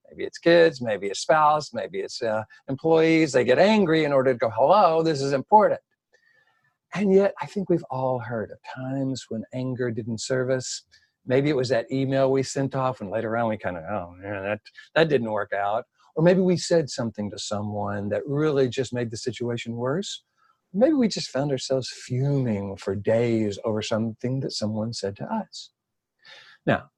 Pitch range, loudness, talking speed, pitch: 110-160 Hz, -24 LUFS, 195 wpm, 130 Hz